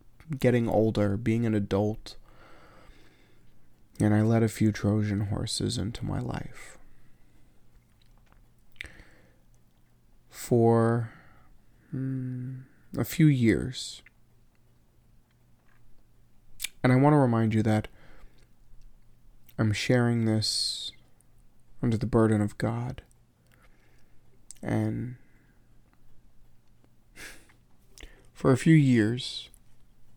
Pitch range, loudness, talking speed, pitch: 100-125 Hz, -27 LUFS, 80 wpm, 110 Hz